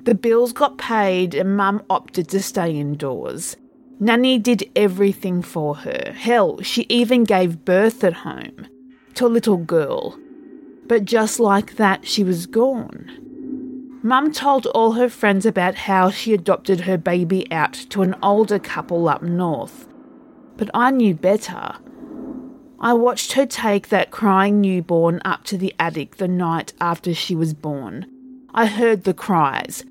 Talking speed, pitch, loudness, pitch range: 150 wpm, 210 Hz, -19 LUFS, 185-255 Hz